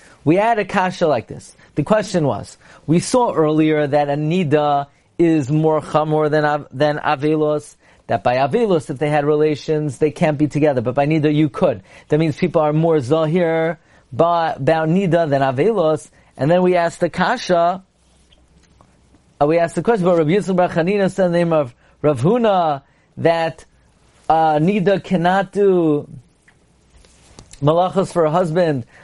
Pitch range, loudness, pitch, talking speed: 150-175 Hz, -17 LUFS, 160 Hz, 165 wpm